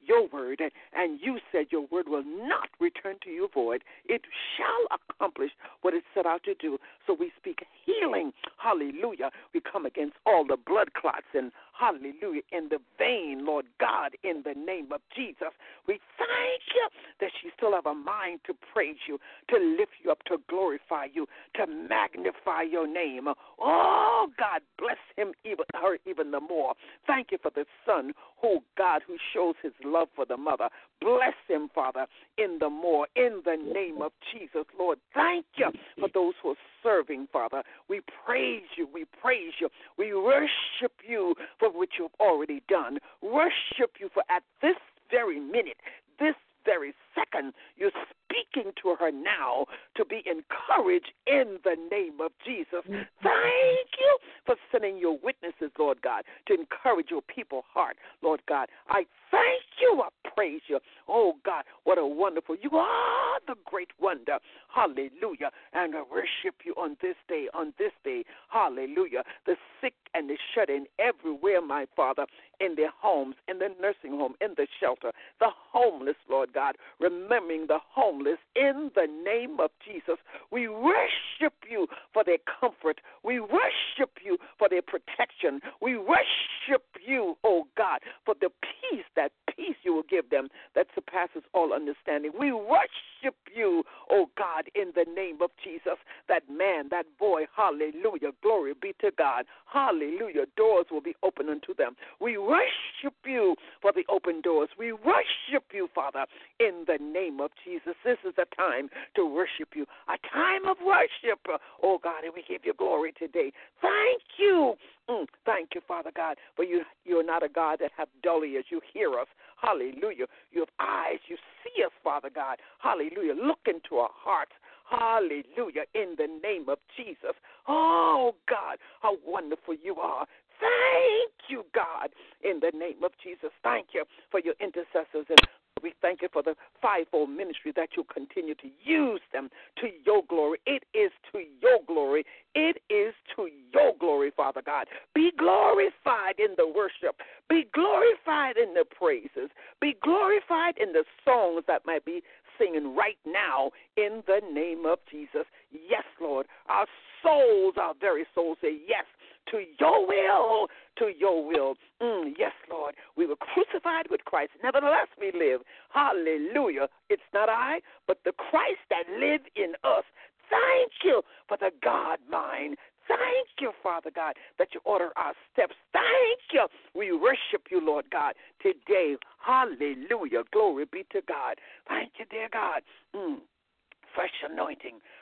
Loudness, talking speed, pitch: -28 LUFS, 160 wpm, 340 Hz